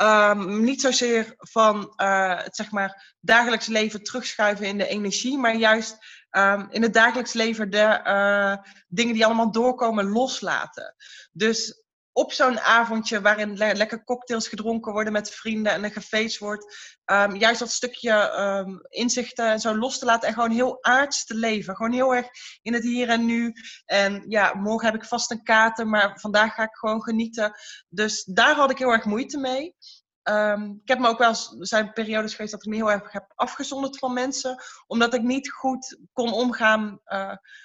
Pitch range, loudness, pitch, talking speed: 210-240 Hz, -23 LUFS, 225 Hz, 175 wpm